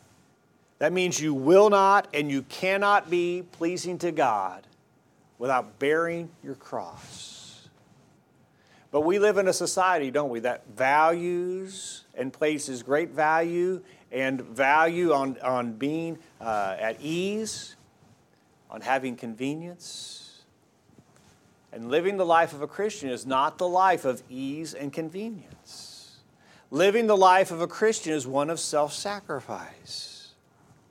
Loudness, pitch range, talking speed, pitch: -26 LUFS, 140-185 Hz, 130 wpm, 165 Hz